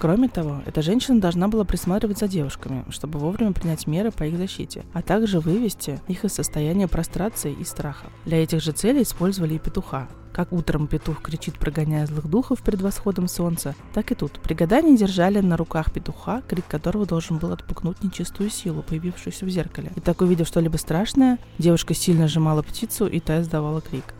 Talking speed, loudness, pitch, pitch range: 185 wpm, -23 LUFS, 170 Hz, 155-195 Hz